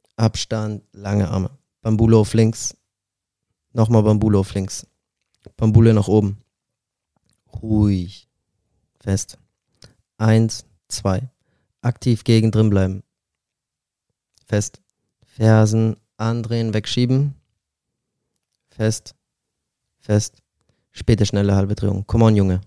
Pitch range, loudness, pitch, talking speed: 100-115 Hz, -19 LUFS, 110 Hz, 90 wpm